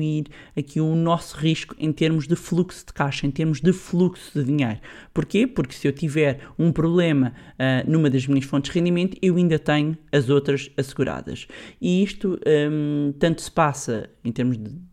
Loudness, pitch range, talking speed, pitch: -22 LUFS, 140-170 Hz, 180 wpm, 155 Hz